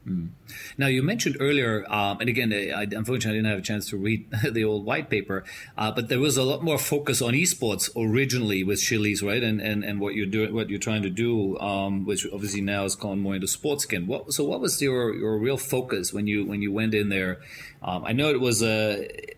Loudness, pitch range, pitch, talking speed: -25 LUFS, 100-125 Hz, 110 Hz, 240 wpm